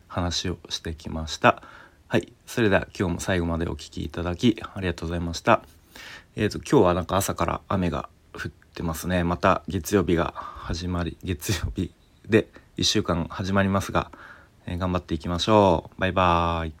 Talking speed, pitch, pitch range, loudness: 345 characters per minute, 90 Hz, 85-95 Hz, -25 LUFS